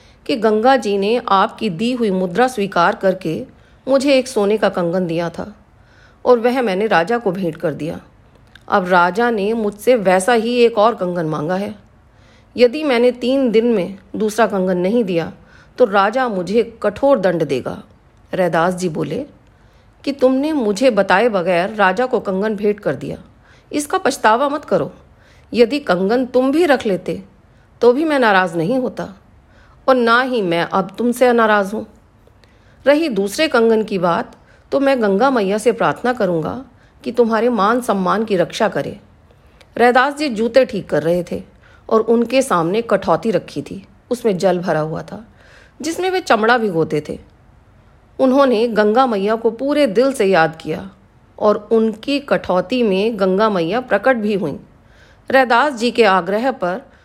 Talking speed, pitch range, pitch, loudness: 165 wpm, 185-250 Hz, 215 Hz, -16 LUFS